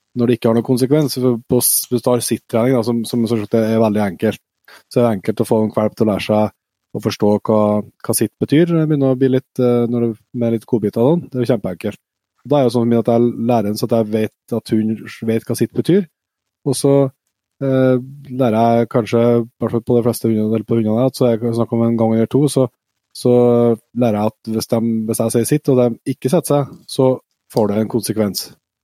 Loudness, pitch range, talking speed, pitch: -17 LUFS, 110-130 Hz, 240 wpm, 120 Hz